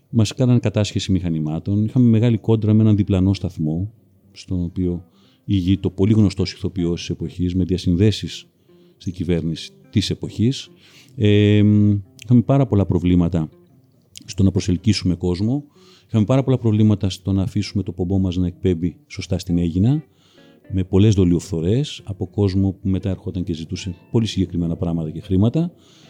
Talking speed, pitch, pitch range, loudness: 145 wpm, 95 Hz, 90-110 Hz, -20 LUFS